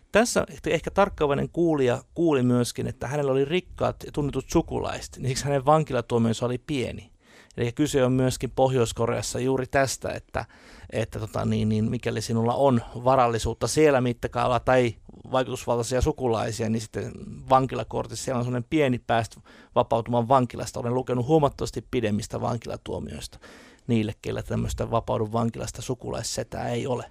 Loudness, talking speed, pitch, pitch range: -25 LUFS, 140 wpm, 125 Hz, 115-135 Hz